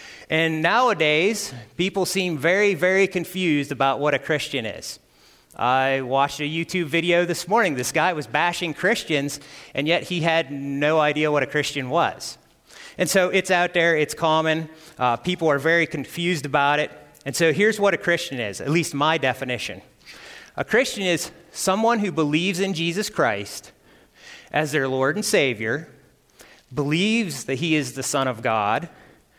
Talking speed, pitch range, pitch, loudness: 165 wpm, 140-175 Hz, 160 Hz, -22 LUFS